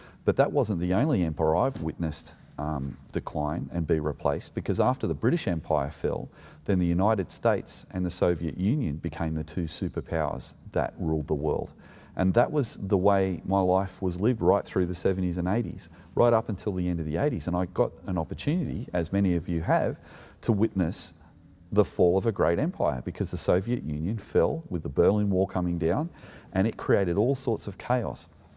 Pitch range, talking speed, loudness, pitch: 80-100 Hz, 195 wpm, -27 LUFS, 90 Hz